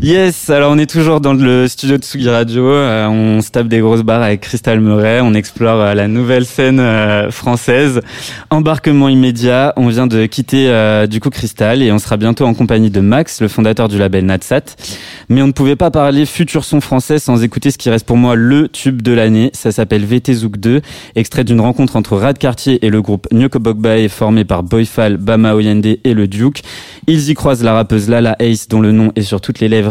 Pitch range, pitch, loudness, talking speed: 110-135 Hz, 120 Hz, -11 LUFS, 220 wpm